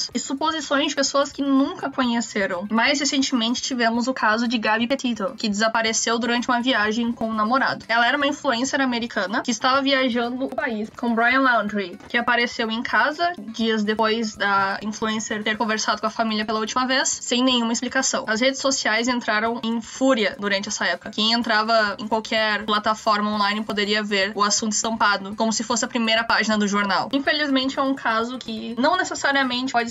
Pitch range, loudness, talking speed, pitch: 220-260 Hz, -21 LUFS, 185 wpm, 235 Hz